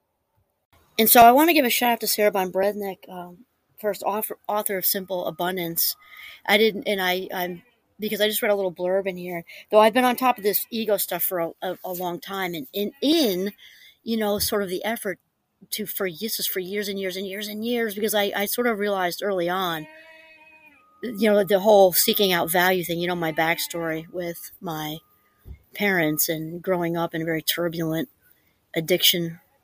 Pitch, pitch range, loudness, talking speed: 195 Hz, 175-215 Hz, -22 LUFS, 200 wpm